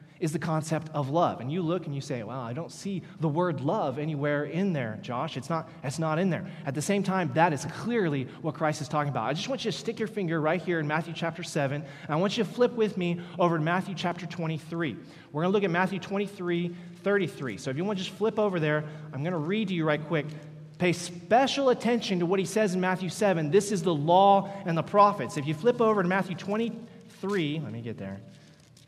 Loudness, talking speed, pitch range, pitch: -28 LUFS, 250 wpm, 155-195 Hz, 175 Hz